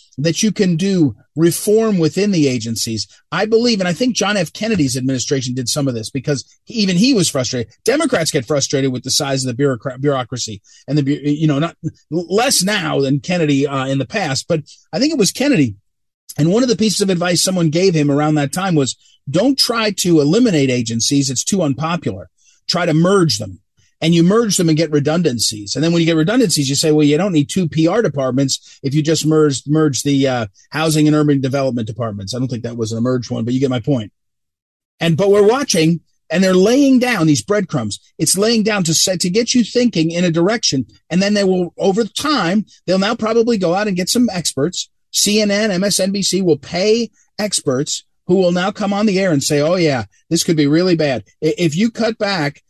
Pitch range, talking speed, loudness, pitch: 140-195 Hz, 215 wpm, -16 LUFS, 160 Hz